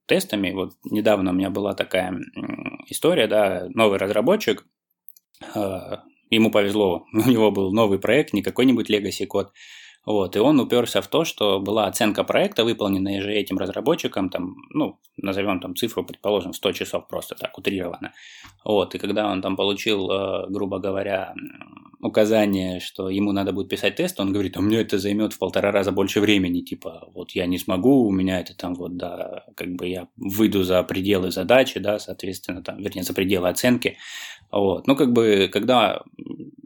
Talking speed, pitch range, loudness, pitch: 170 wpm, 95-105 Hz, -22 LUFS, 100 Hz